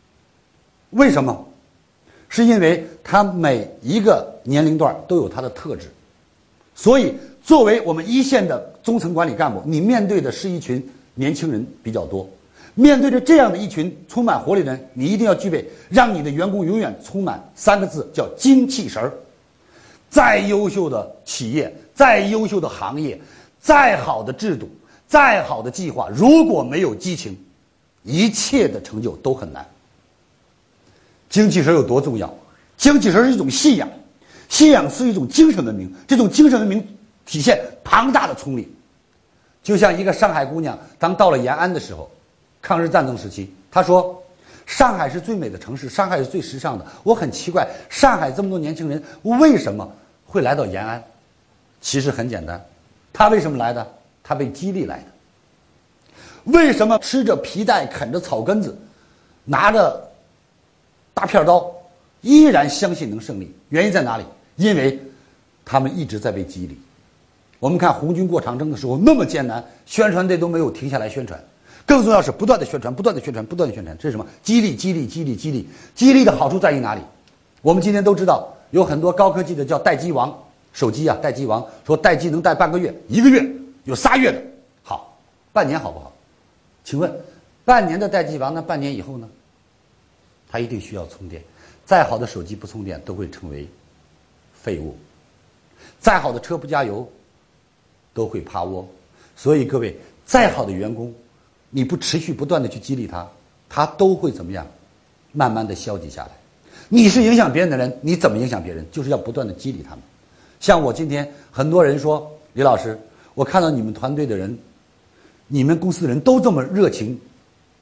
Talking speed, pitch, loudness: 265 characters per minute, 160 Hz, -17 LUFS